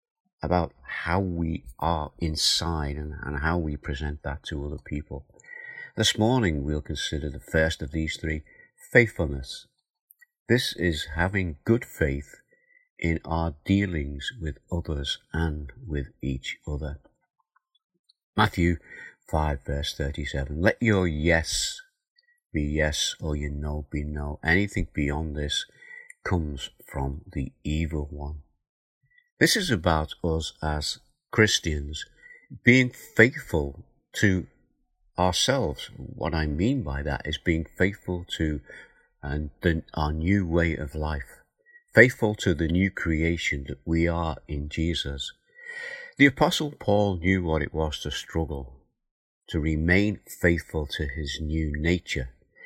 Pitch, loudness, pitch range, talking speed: 80 Hz, -26 LUFS, 75-100 Hz, 125 wpm